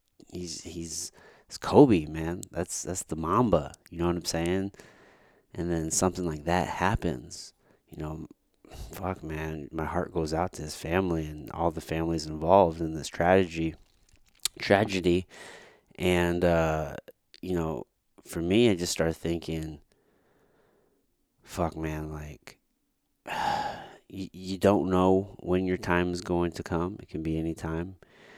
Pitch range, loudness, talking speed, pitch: 80-90 Hz, -28 LUFS, 145 wpm, 85 Hz